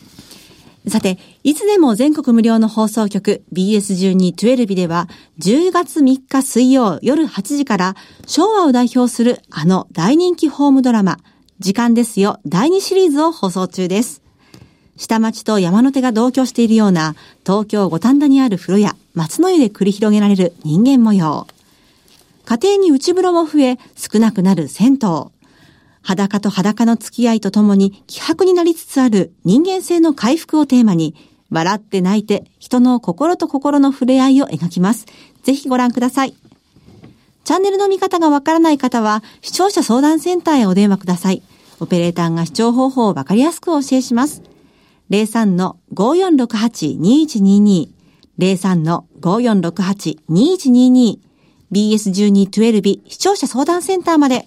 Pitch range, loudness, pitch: 195-275 Hz, -14 LUFS, 230 Hz